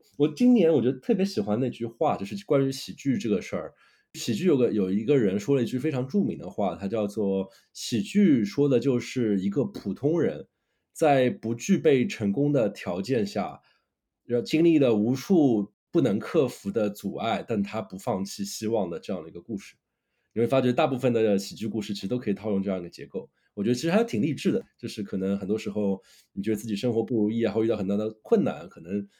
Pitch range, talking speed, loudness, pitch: 100-135 Hz, 325 characters per minute, -26 LUFS, 110 Hz